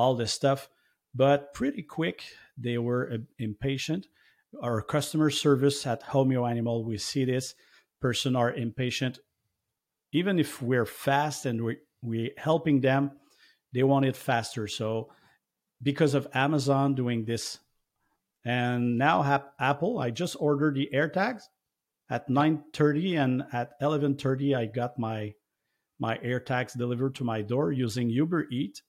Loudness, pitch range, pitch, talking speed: -28 LUFS, 120-145 Hz, 130 Hz, 140 wpm